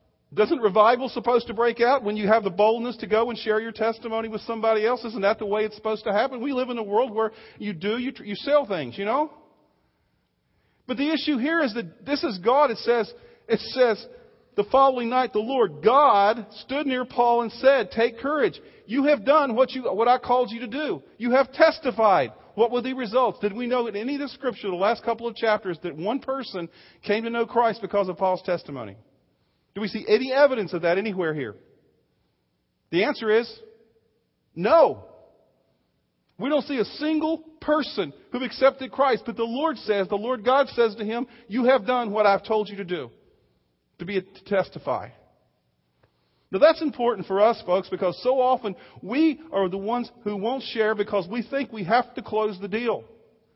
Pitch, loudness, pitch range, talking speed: 230 Hz, -24 LUFS, 210-260 Hz, 200 wpm